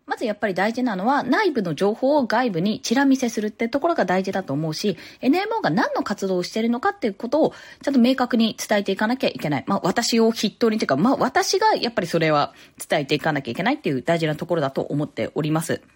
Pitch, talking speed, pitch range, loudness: 220 Hz, 505 characters per minute, 175-255 Hz, -22 LUFS